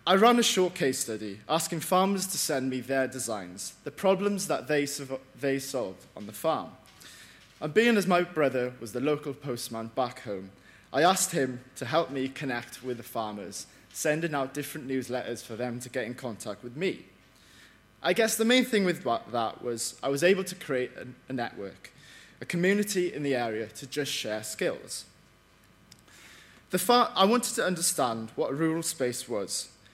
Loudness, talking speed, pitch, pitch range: -29 LUFS, 185 wpm, 130 Hz, 120-170 Hz